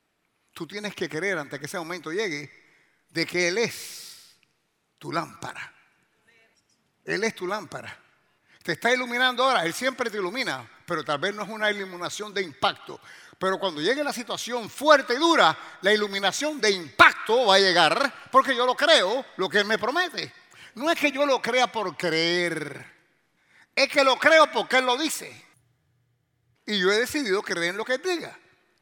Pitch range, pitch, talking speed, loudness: 175-260 Hz, 210 Hz, 180 wpm, -23 LUFS